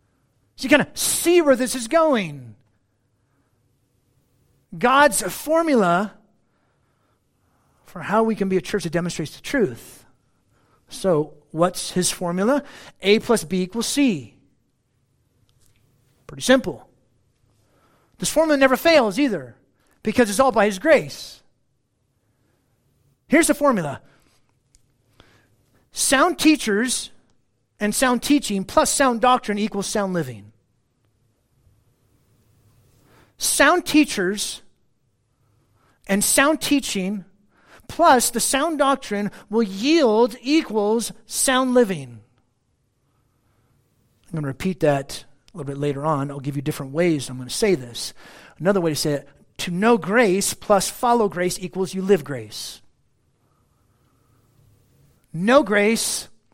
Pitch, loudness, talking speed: 170 Hz, -20 LUFS, 115 wpm